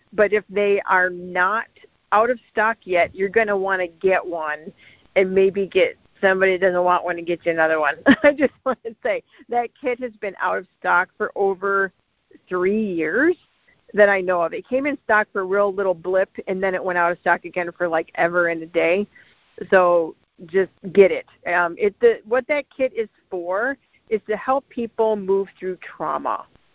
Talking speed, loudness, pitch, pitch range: 205 wpm, -21 LUFS, 195 Hz, 180-225 Hz